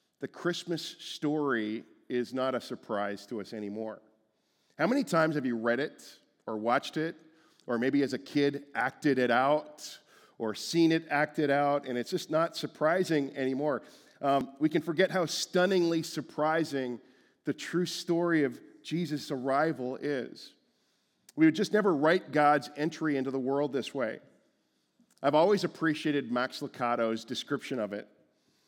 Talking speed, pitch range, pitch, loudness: 155 wpm, 130-165 Hz, 145 Hz, -30 LUFS